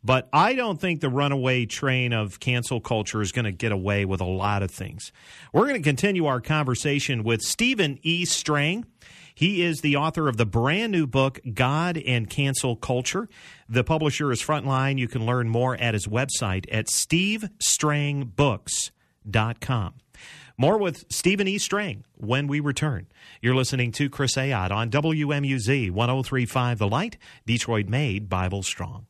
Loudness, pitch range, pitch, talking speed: -24 LUFS, 115-150 Hz, 130 Hz, 160 wpm